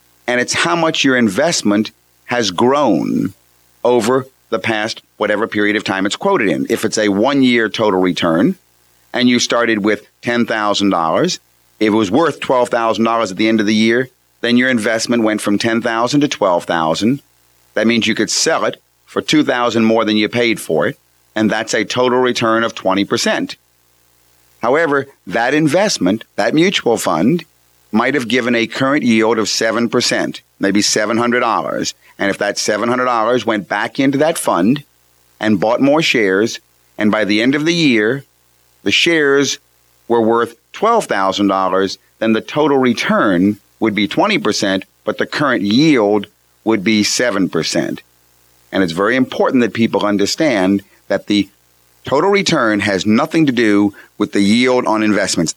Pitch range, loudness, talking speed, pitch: 95-120 Hz, -15 LUFS, 155 wpm, 110 Hz